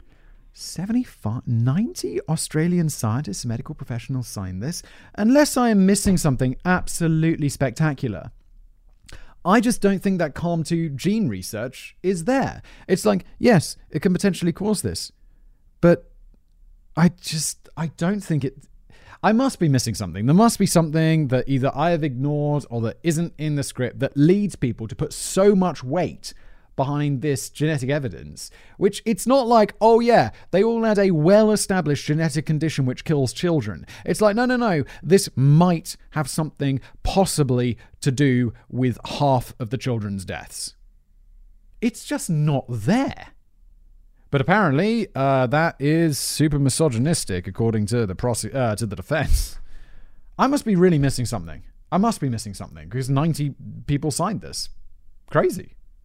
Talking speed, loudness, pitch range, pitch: 155 wpm, -21 LUFS, 120-180 Hz, 150 Hz